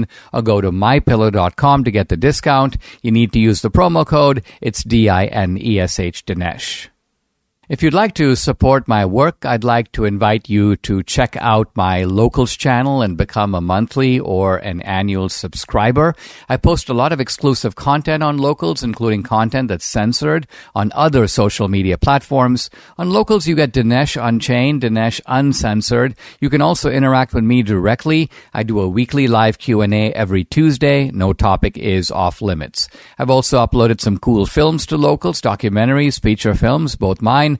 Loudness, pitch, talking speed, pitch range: -15 LUFS, 115 Hz, 175 wpm, 105-140 Hz